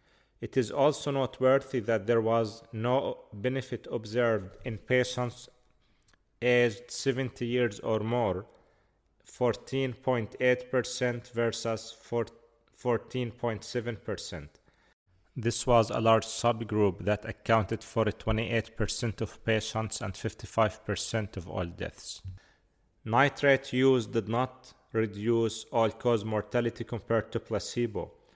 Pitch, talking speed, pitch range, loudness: 115 Hz, 100 wpm, 110-125 Hz, -30 LUFS